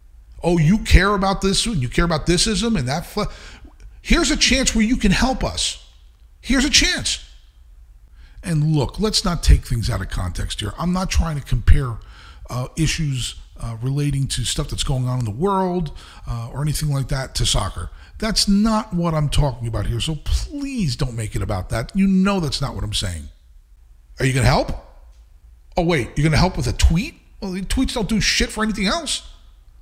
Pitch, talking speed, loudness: 135 Hz, 200 wpm, -20 LUFS